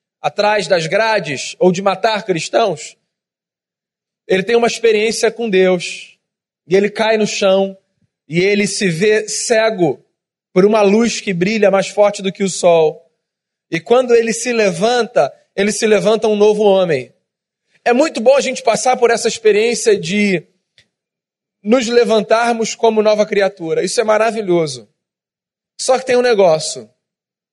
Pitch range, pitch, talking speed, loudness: 190-230 Hz, 210 Hz, 150 wpm, -14 LUFS